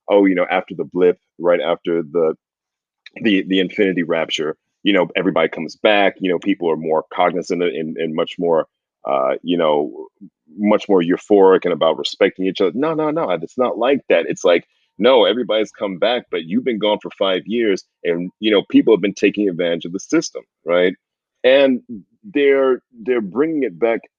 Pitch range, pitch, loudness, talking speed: 90-145 Hz, 100 Hz, -18 LUFS, 190 wpm